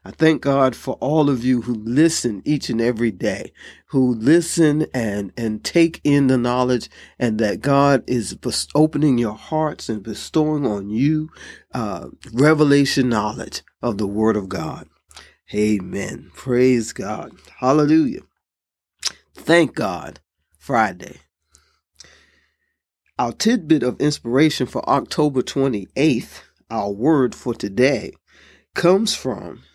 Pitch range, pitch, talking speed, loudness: 110-150 Hz, 130 Hz, 120 wpm, -19 LUFS